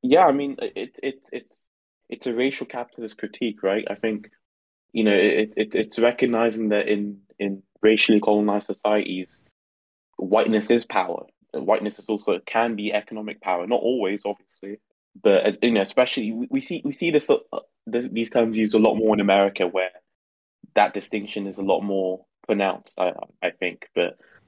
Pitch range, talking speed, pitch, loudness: 100-120 Hz, 175 wpm, 110 Hz, -23 LUFS